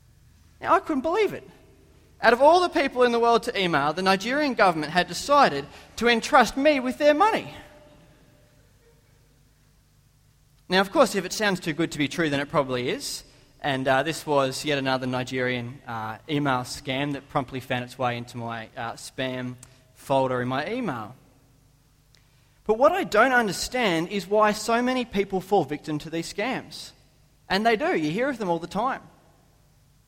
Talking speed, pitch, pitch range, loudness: 180 wpm, 150 Hz, 135-215 Hz, -24 LUFS